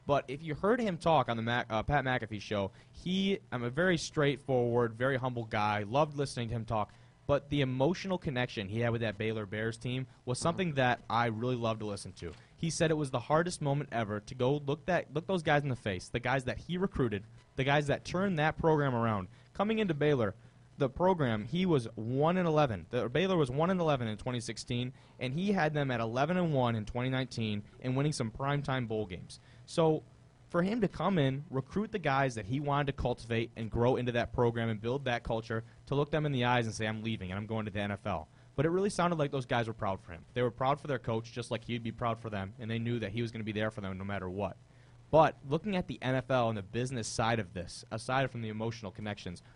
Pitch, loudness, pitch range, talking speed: 125 Hz, -33 LUFS, 115-145 Hz, 250 wpm